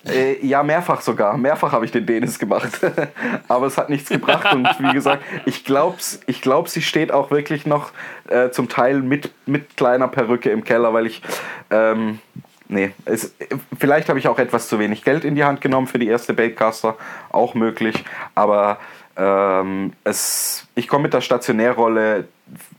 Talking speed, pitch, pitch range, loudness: 175 wpm, 120 Hz, 110-135 Hz, -19 LUFS